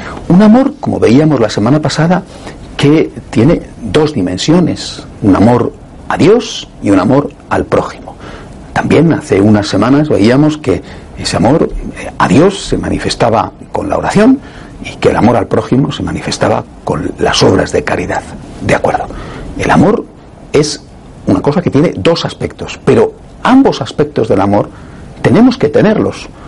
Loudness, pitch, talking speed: -11 LUFS, 150 Hz, 150 wpm